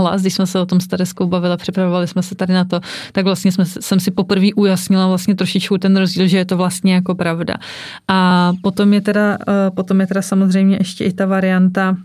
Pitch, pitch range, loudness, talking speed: 190 Hz, 185-195 Hz, -15 LUFS, 215 wpm